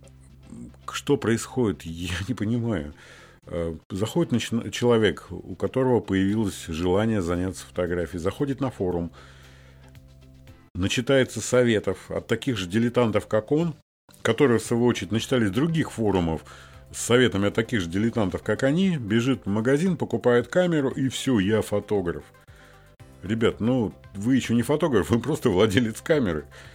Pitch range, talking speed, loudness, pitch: 90-125 Hz, 130 wpm, -24 LUFS, 110 Hz